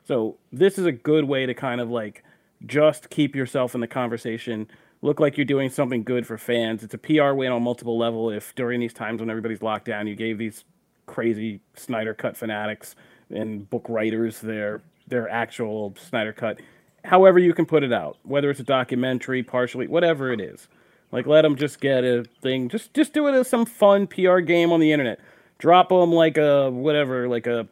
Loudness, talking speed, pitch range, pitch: -22 LUFS, 205 wpm, 115-155 Hz, 125 Hz